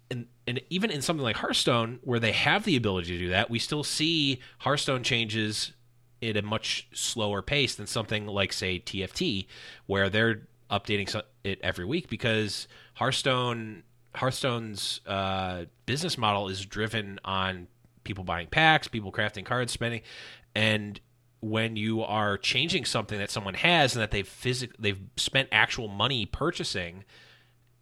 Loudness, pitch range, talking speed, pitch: -28 LUFS, 100-125 Hz, 150 wpm, 115 Hz